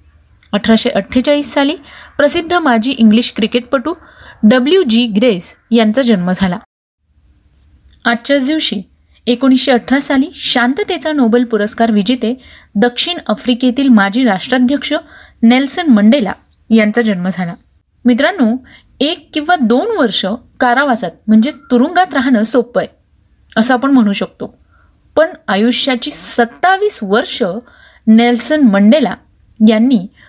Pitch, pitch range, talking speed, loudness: 245 Hz, 220-275 Hz, 105 wpm, -12 LUFS